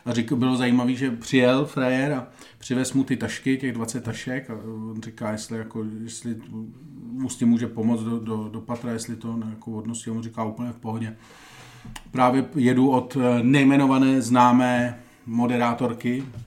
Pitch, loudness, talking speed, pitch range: 120 Hz, -23 LUFS, 170 wpm, 115-130 Hz